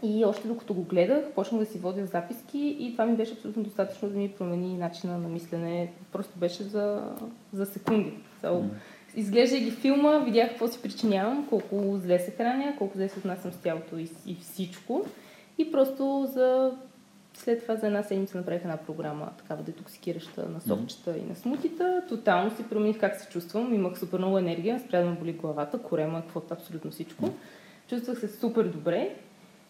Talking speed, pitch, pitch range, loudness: 175 wpm, 200 Hz, 180-235 Hz, -30 LUFS